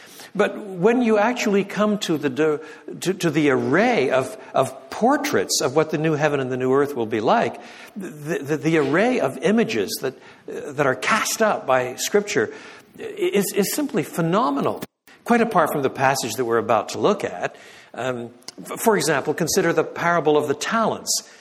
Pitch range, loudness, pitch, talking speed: 145-215 Hz, -21 LUFS, 170 Hz, 175 wpm